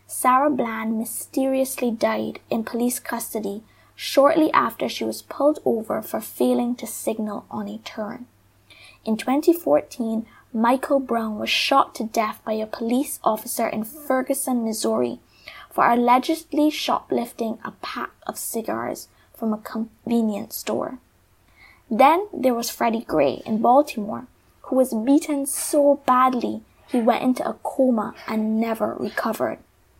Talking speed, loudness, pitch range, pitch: 130 wpm, -23 LUFS, 220-275 Hz, 240 Hz